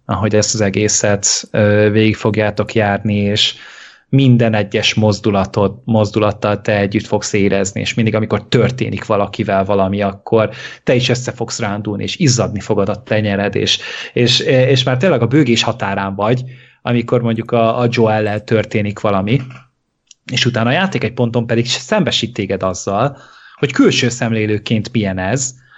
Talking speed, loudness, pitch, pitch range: 150 wpm, -15 LUFS, 110 Hz, 105-120 Hz